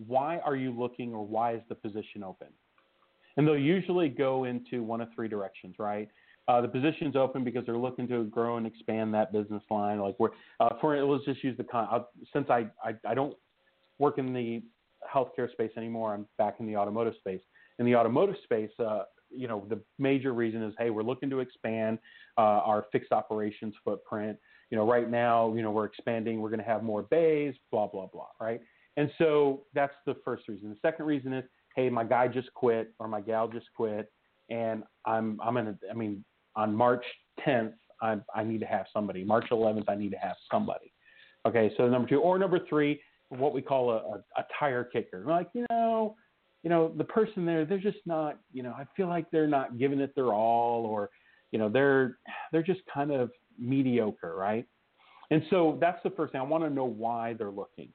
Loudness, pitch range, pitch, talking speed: -31 LUFS, 110-140 Hz, 120 Hz, 210 wpm